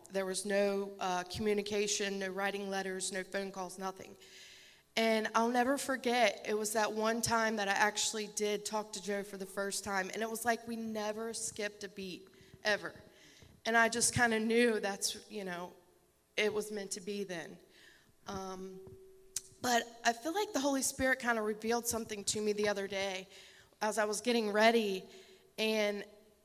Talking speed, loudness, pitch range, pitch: 180 wpm, -34 LUFS, 195-225 Hz, 210 Hz